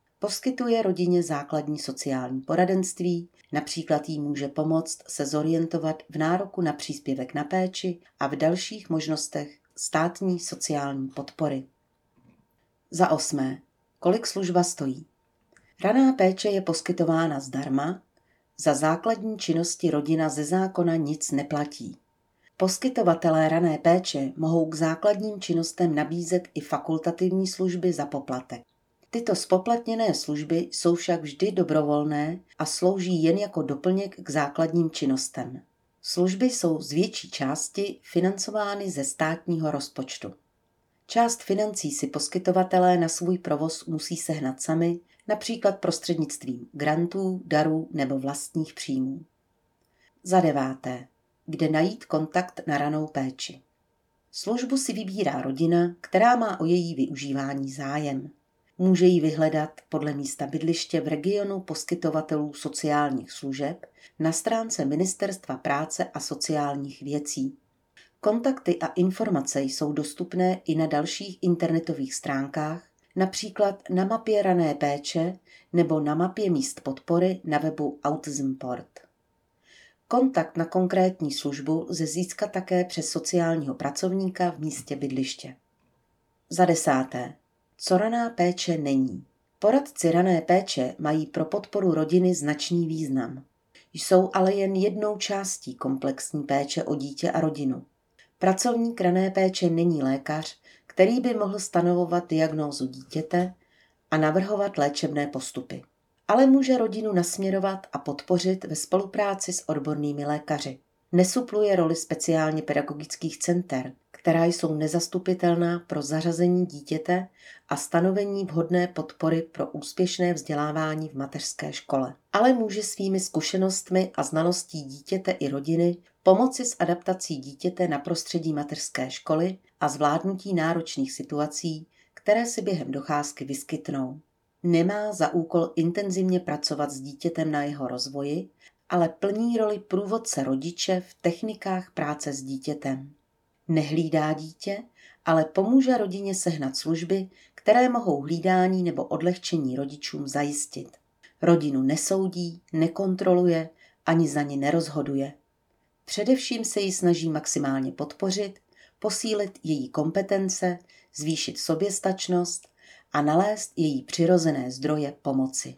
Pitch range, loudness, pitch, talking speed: 145-185 Hz, -26 LUFS, 165 Hz, 120 wpm